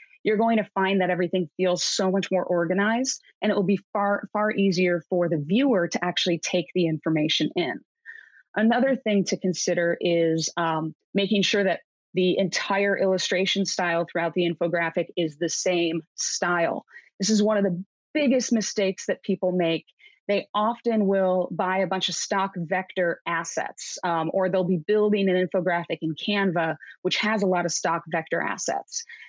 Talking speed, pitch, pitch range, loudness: 170 wpm, 185 Hz, 175-205 Hz, -24 LUFS